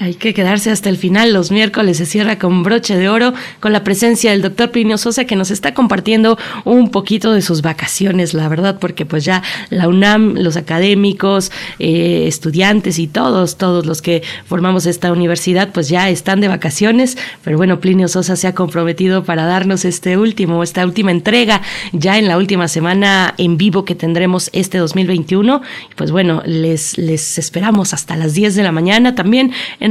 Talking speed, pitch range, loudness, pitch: 185 wpm, 175-210 Hz, -13 LUFS, 185 Hz